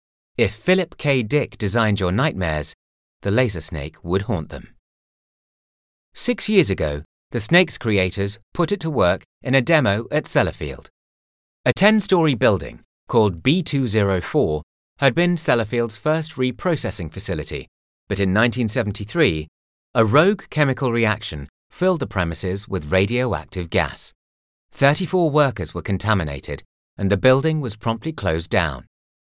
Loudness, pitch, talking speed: -20 LUFS, 105 Hz, 130 wpm